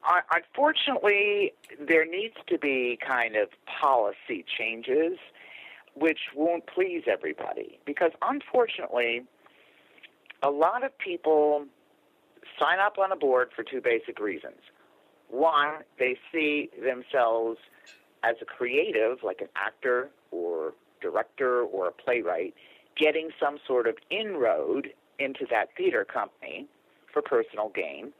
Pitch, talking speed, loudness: 175 Hz, 115 wpm, -28 LUFS